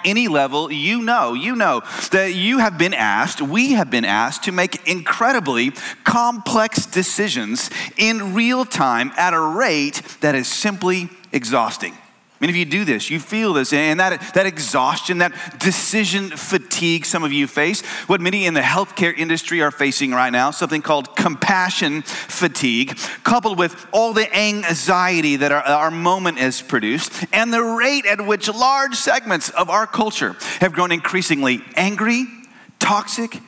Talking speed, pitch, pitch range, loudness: 160 wpm, 185 Hz, 160-220 Hz, -18 LUFS